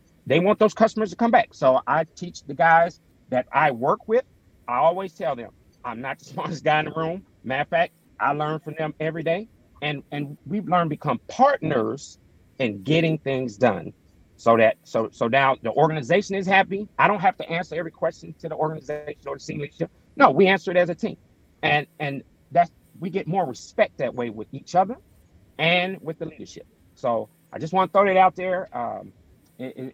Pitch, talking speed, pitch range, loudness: 160 Hz, 210 wpm, 140-185 Hz, -23 LUFS